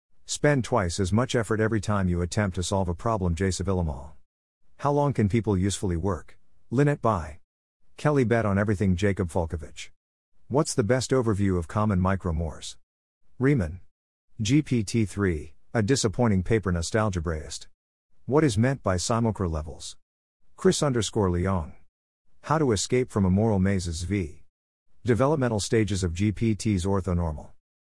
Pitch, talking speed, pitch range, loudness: 100 Hz, 135 wpm, 85-115 Hz, -26 LUFS